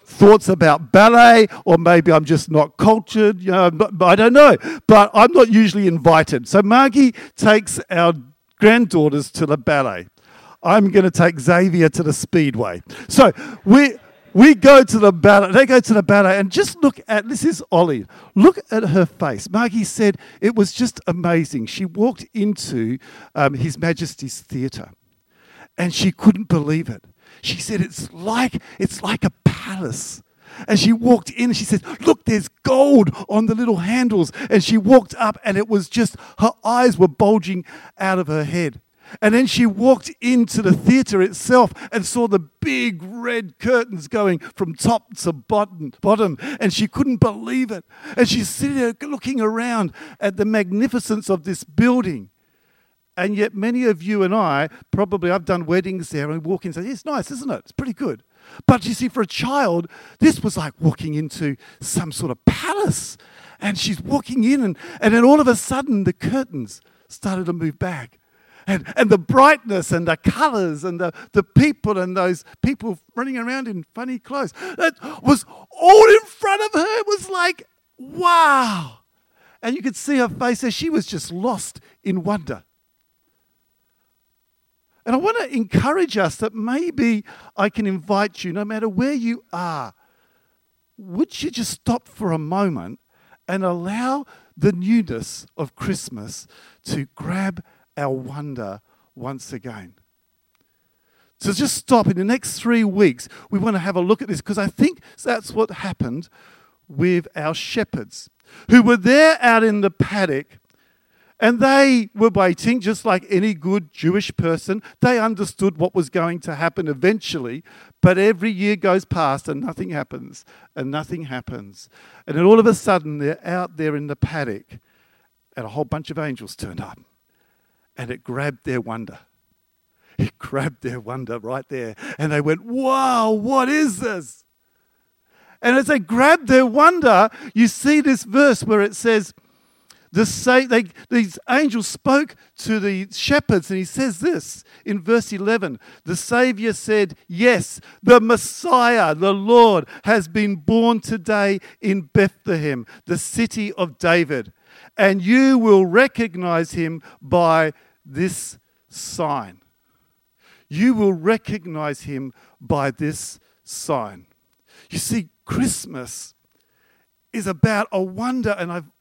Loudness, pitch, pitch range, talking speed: -17 LUFS, 205 Hz, 170-235 Hz, 160 wpm